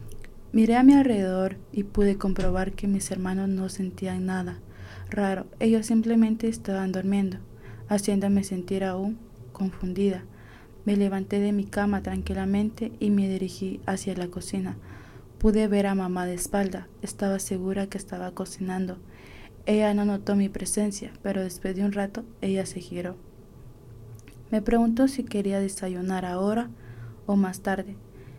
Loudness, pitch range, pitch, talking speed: -26 LUFS, 180-205 Hz, 195 Hz, 140 wpm